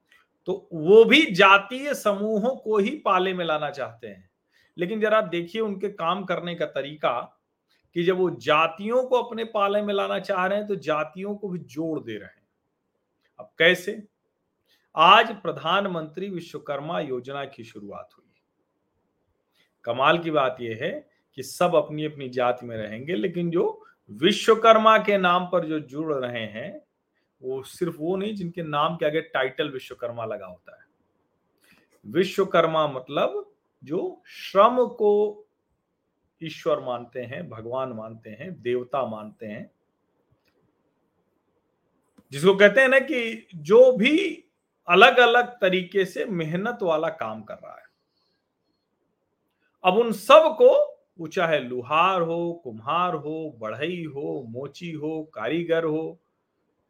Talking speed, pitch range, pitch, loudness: 140 wpm, 150-210 Hz, 175 Hz, -22 LUFS